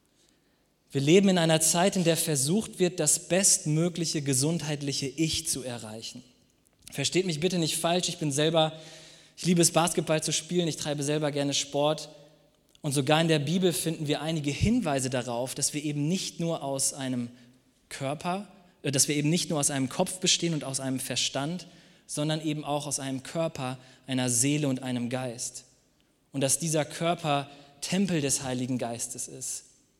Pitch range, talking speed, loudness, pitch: 135-165 Hz, 170 wpm, -27 LUFS, 150 Hz